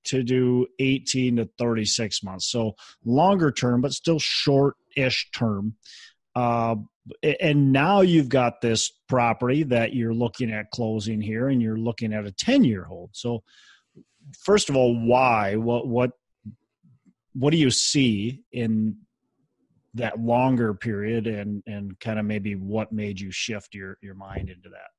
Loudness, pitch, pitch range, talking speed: -23 LUFS, 115 Hz, 110-130 Hz, 150 wpm